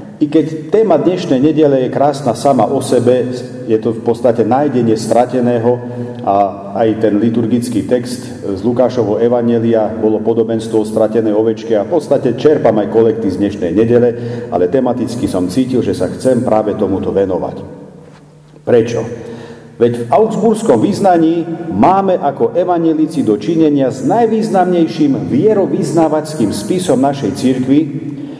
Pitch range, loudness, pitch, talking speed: 115-155 Hz, -13 LUFS, 125 Hz, 130 wpm